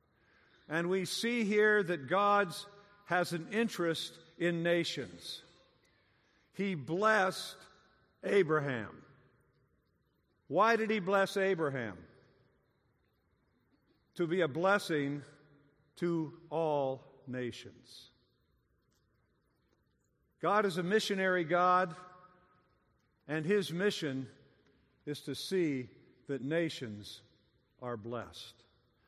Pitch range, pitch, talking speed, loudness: 125-185 Hz, 160 Hz, 85 wpm, -33 LUFS